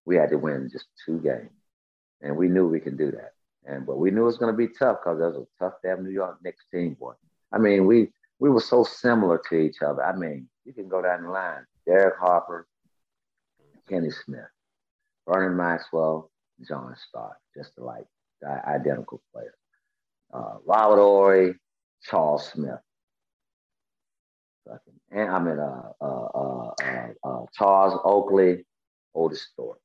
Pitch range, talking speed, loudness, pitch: 80-100 Hz, 170 wpm, -24 LUFS, 95 Hz